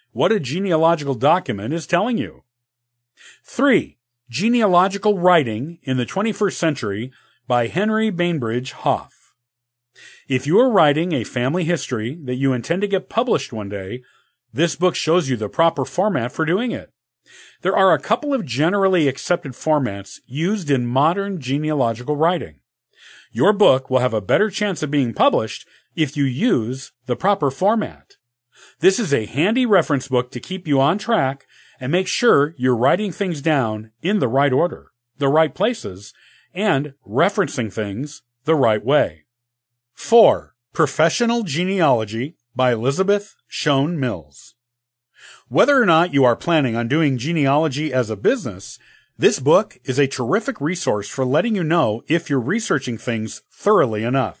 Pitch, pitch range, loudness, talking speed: 145 Hz, 125-175 Hz, -19 LUFS, 150 wpm